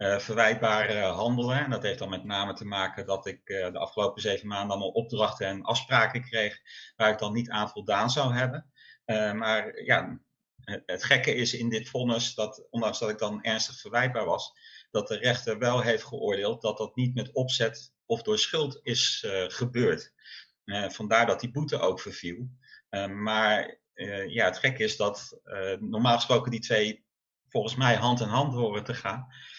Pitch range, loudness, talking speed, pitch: 105-130 Hz, -28 LUFS, 190 wpm, 115 Hz